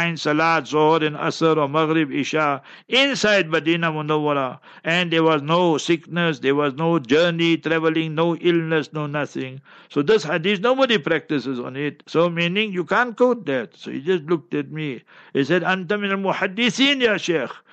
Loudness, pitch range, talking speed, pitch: -20 LUFS, 150-185 Hz, 160 wpm, 165 Hz